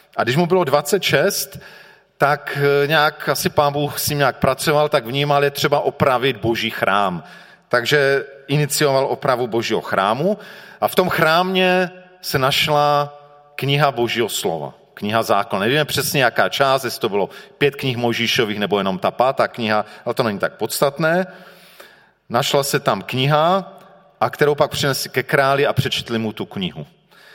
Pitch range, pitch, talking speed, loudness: 130-160 Hz, 145 Hz, 160 wpm, -18 LUFS